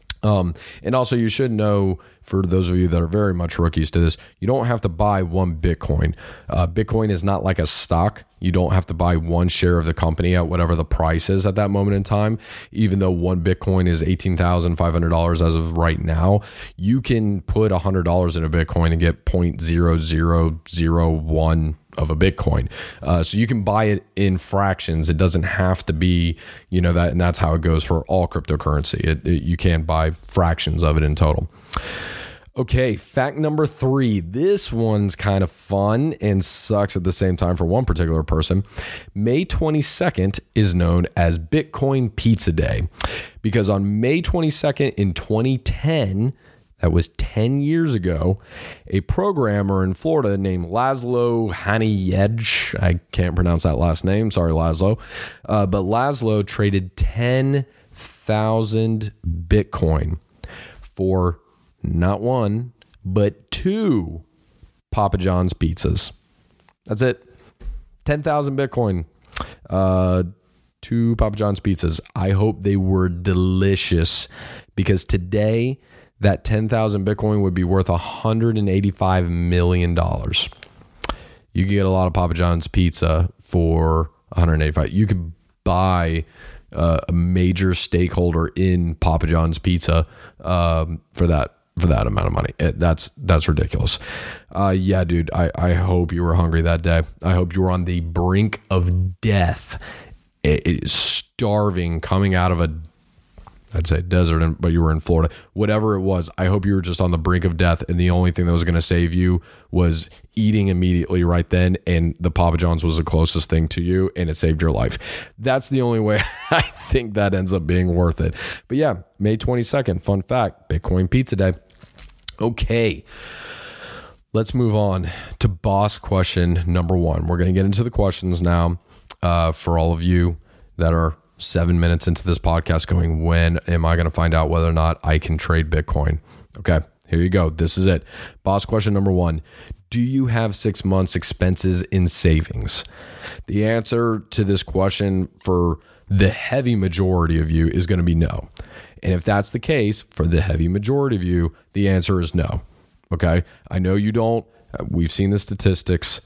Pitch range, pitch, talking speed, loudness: 85-105 Hz, 90 Hz, 170 wpm, -20 LUFS